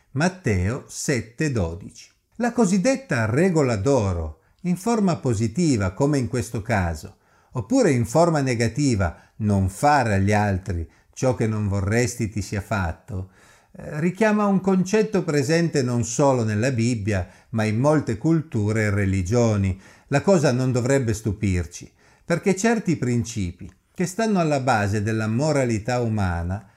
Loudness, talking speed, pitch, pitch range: -22 LUFS, 130 wpm, 120 Hz, 100-150 Hz